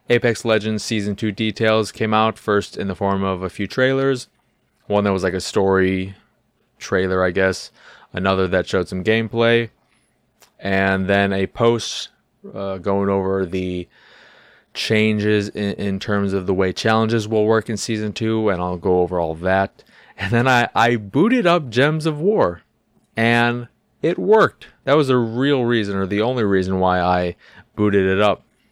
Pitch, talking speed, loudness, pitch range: 105 Hz, 170 wpm, -19 LUFS, 95-115 Hz